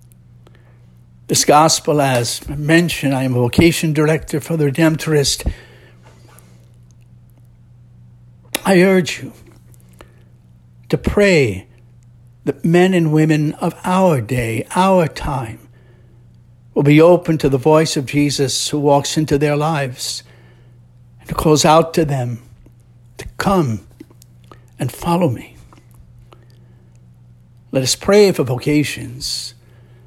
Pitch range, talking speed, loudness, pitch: 120-155 Hz, 110 wpm, -15 LUFS, 125 Hz